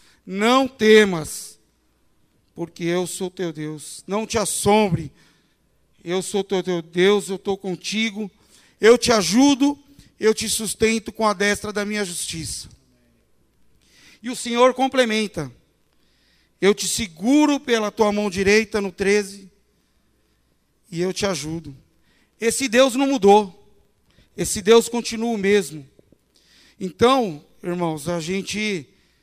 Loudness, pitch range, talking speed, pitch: -20 LUFS, 180-225 Hz, 120 wpm, 205 Hz